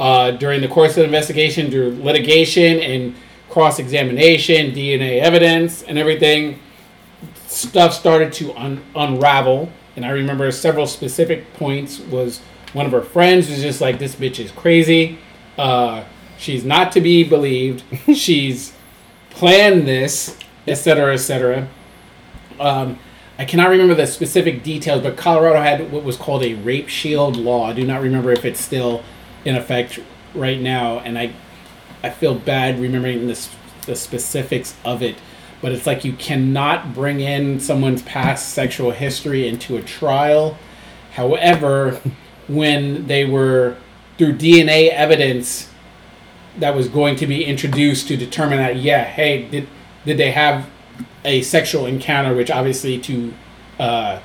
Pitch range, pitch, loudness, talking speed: 130-155 Hz, 140 Hz, -16 LUFS, 145 wpm